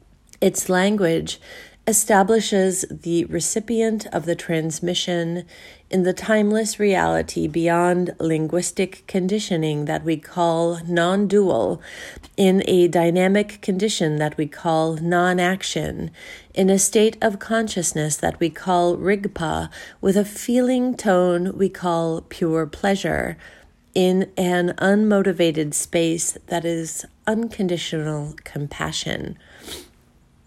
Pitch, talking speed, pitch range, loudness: 180 Hz, 105 wpm, 165-200 Hz, -21 LUFS